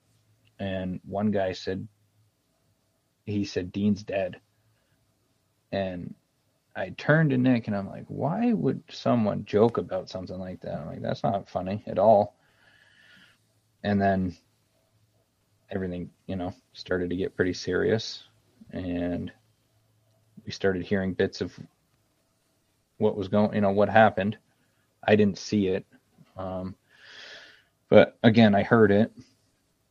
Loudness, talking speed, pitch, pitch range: -26 LUFS, 130 wpm, 105 Hz, 95-110 Hz